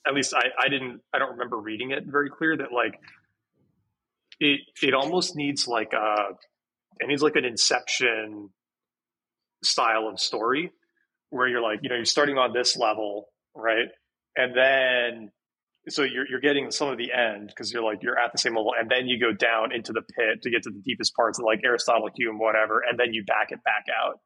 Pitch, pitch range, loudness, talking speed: 120 Hz, 110-135 Hz, -25 LUFS, 205 wpm